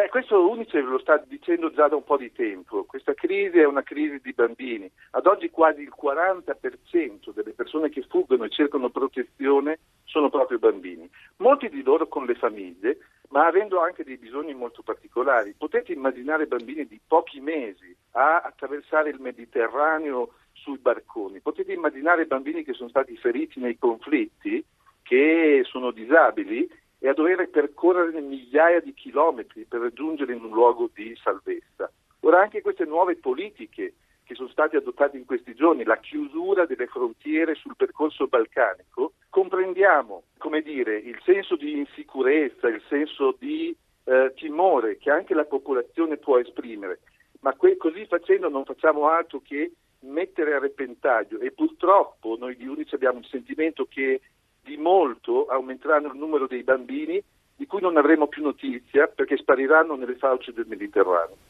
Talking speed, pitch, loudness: 155 wpm, 300 Hz, -24 LUFS